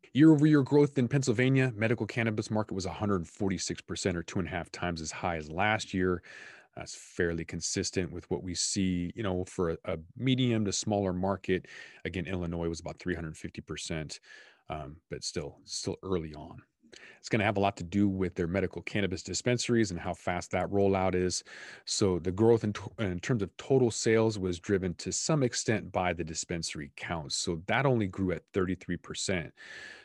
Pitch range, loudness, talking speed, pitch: 90-115 Hz, -31 LUFS, 190 wpm, 95 Hz